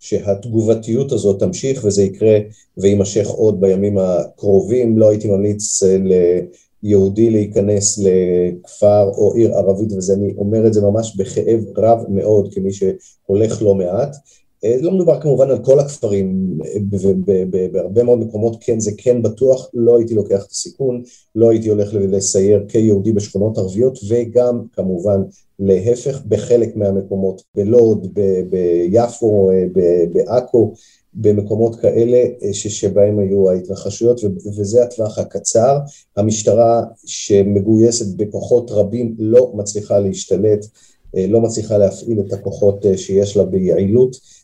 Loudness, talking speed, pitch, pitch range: -15 LUFS, 125 wpm, 105 Hz, 100-115 Hz